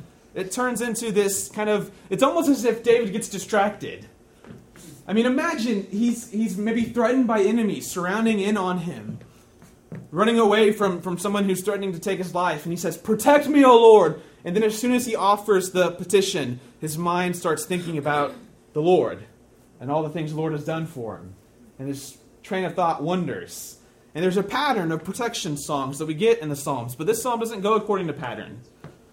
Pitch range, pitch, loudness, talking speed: 160-220 Hz, 195 Hz, -22 LUFS, 200 wpm